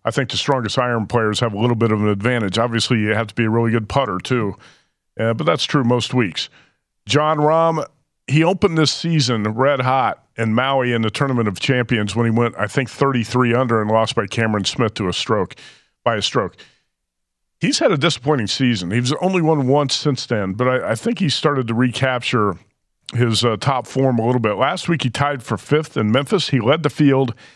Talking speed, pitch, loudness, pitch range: 220 wpm, 125 Hz, -18 LUFS, 115-140 Hz